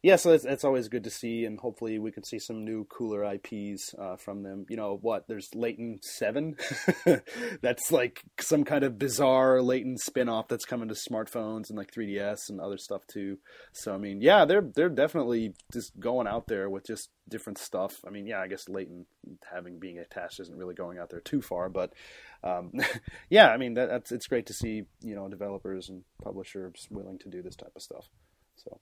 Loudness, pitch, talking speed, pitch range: -29 LUFS, 110 Hz, 215 wpm, 95-120 Hz